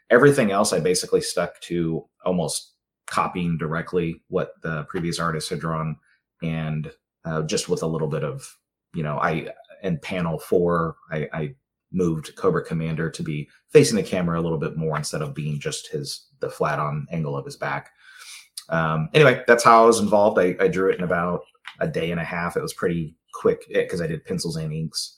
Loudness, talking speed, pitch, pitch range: -23 LUFS, 195 wpm, 85 Hz, 80-90 Hz